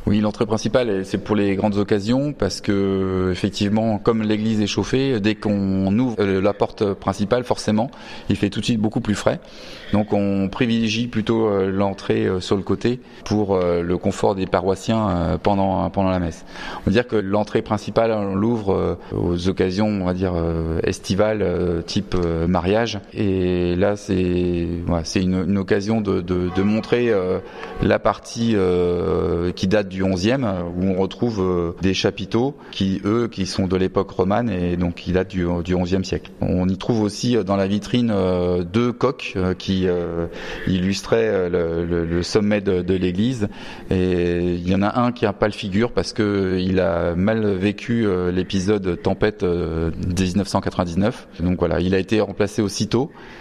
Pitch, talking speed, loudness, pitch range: 100 Hz, 170 wpm, -21 LUFS, 90-110 Hz